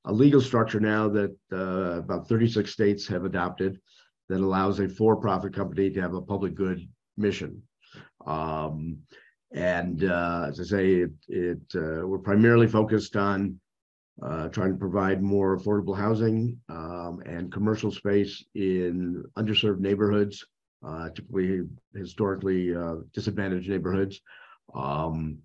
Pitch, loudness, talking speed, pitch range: 95 Hz, -27 LUFS, 130 wpm, 90-105 Hz